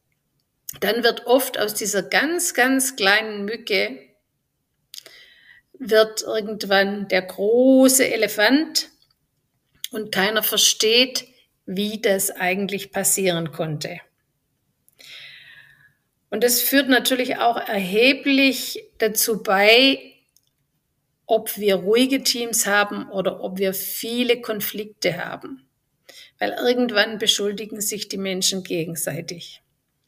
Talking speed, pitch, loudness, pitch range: 95 wpm, 210 Hz, -20 LUFS, 190-245 Hz